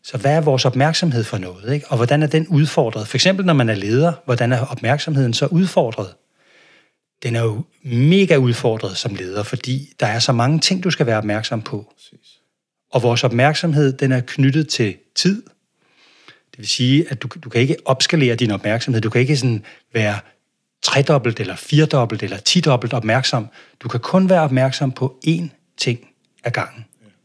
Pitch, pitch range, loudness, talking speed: 130 Hz, 115-150 Hz, -18 LUFS, 180 wpm